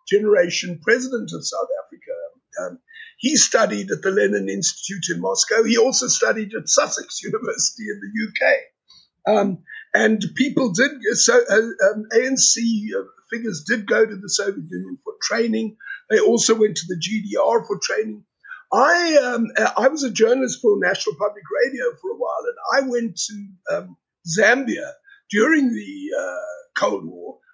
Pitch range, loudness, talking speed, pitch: 210-290 Hz, -19 LUFS, 155 wpm, 230 Hz